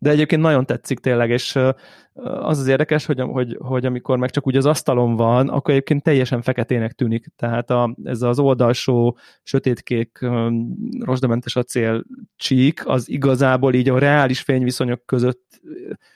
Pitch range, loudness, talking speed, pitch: 120-140 Hz, -19 LUFS, 150 wpm, 130 Hz